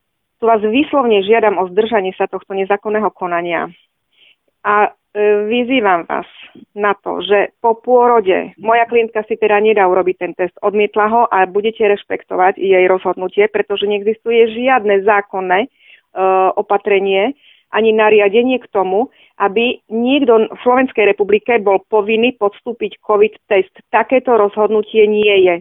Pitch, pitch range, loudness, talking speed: 210 Hz, 195-230 Hz, -14 LUFS, 135 wpm